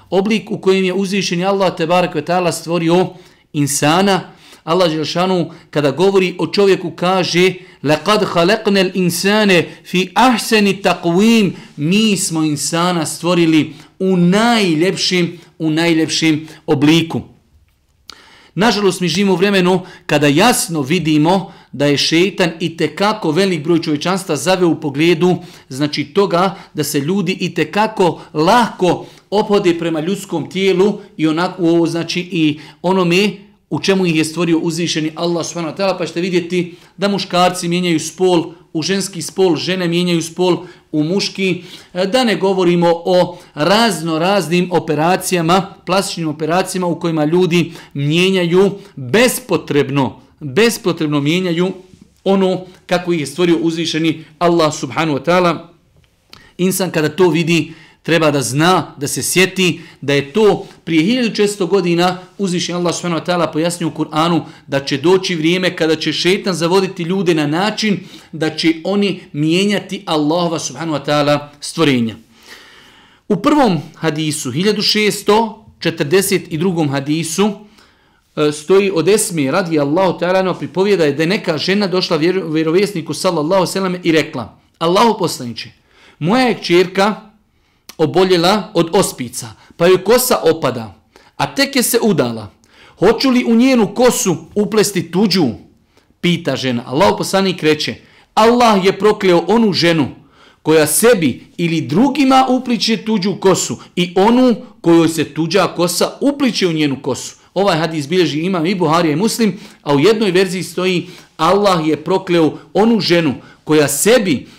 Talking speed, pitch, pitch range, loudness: 140 wpm, 175 Hz, 160-190 Hz, -15 LUFS